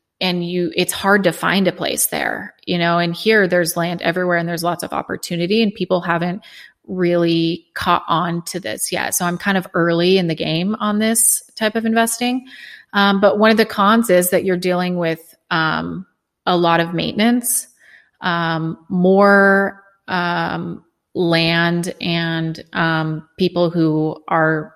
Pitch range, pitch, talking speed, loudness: 170-200 Hz, 180 Hz, 165 wpm, -17 LUFS